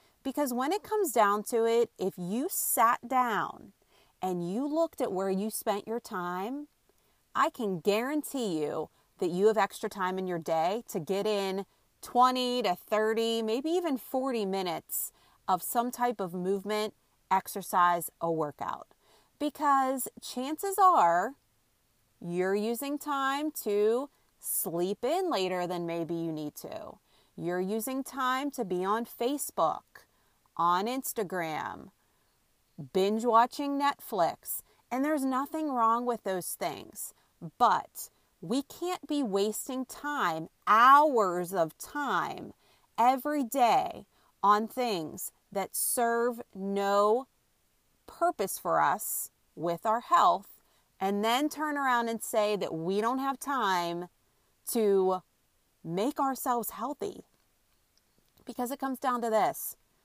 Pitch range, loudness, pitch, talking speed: 190-265 Hz, -30 LUFS, 225 Hz, 125 wpm